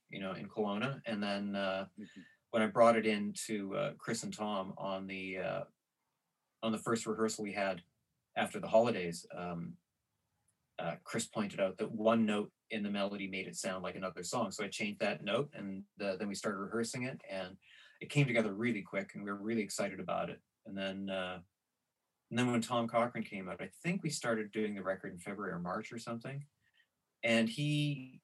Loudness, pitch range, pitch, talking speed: -37 LUFS, 95-115 Hz, 110 Hz, 205 wpm